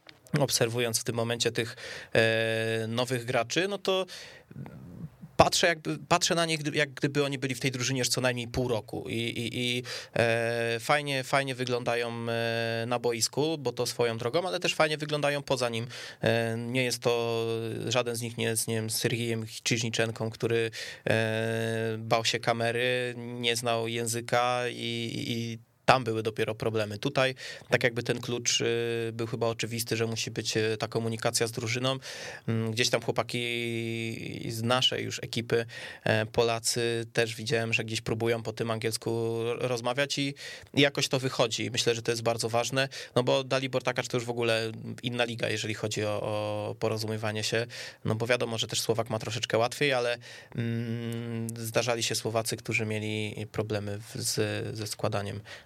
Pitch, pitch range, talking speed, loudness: 115 Hz, 115-125 Hz, 160 wpm, -29 LUFS